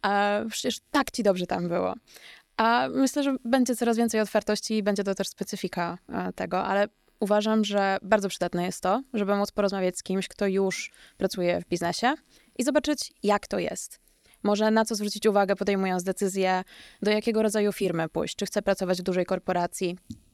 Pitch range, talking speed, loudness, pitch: 185-220 Hz, 175 wpm, -27 LUFS, 200 Hz